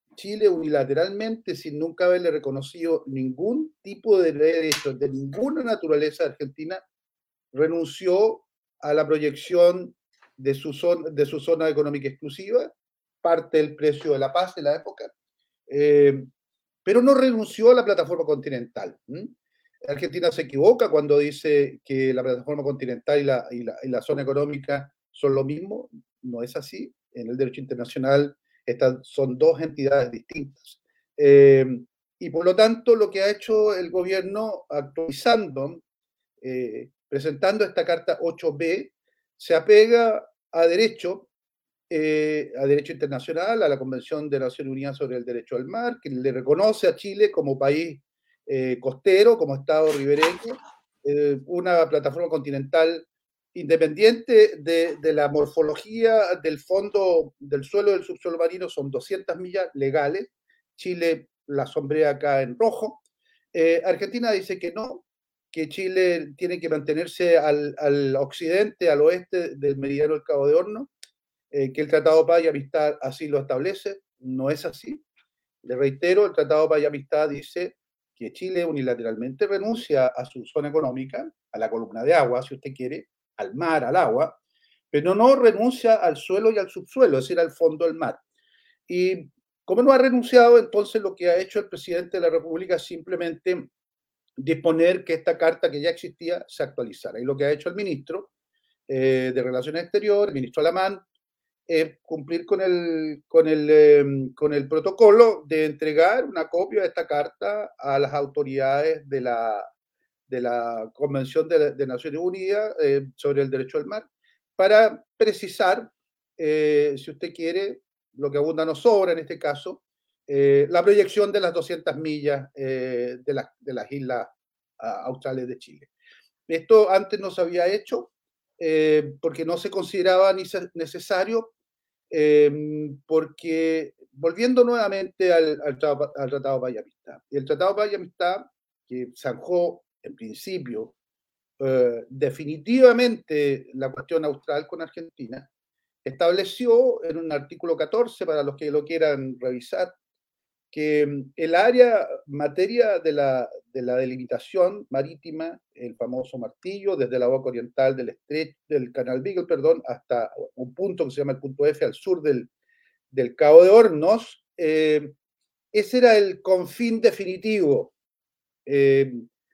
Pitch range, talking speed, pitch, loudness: 140-205 Hz, 150 wpm, 165 Hz, -22 LUFS